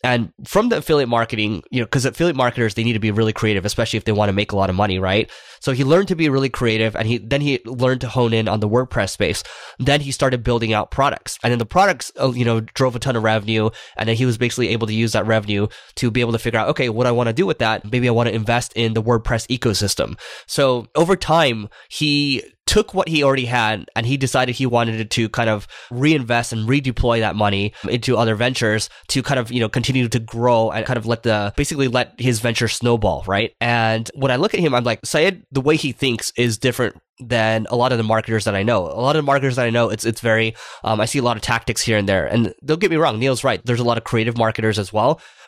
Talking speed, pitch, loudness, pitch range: 265 wpm, 120 Hz, -19 LUFS, 110-130 Hz